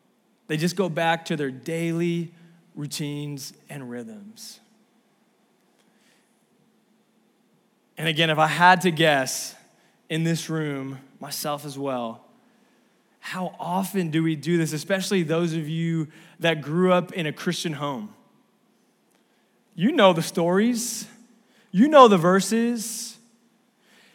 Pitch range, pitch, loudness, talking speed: 160-225 Hz, 180 Hz, -23 LUFS, 120 wpm